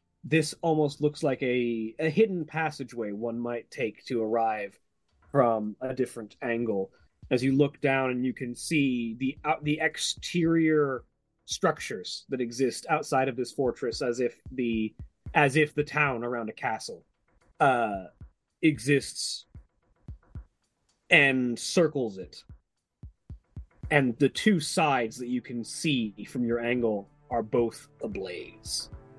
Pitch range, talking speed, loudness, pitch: 120-150 Hz, 135 wpm, -28 LUFS, 130 Hz